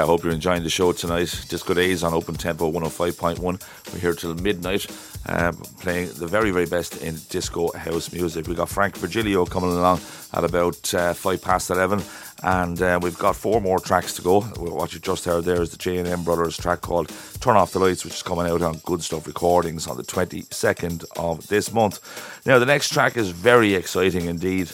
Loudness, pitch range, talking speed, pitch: -22 LUFS, 85-95 Hz, 205 wpm, 90 Hz